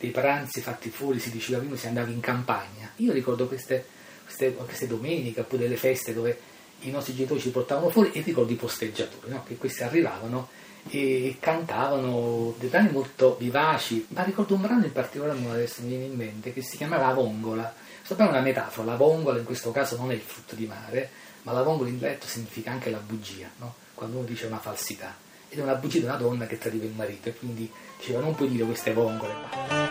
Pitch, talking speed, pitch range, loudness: 125 Hz, 215 wpm, 115-135 Hz, -28 LUFS